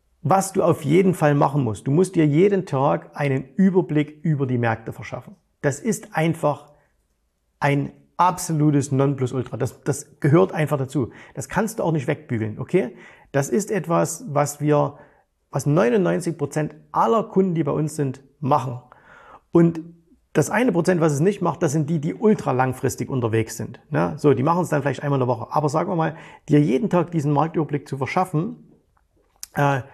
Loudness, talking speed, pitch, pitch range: -21 LUFS, 175 wpm, 150 Hz, 135-170 Hz